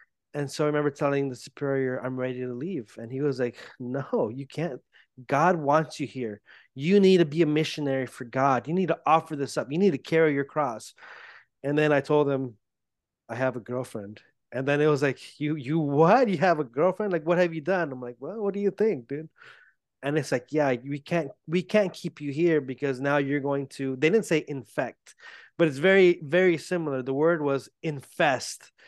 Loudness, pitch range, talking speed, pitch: -26 LUFS, 135-165 Hz, 220 wpm, 145 Hz